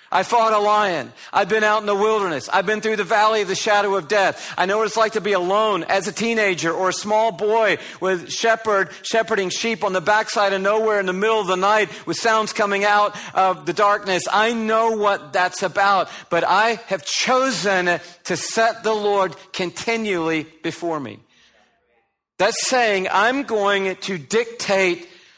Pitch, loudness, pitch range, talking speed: 205 Hz, -19 LUFS, 185-220 Hz, 185 wpm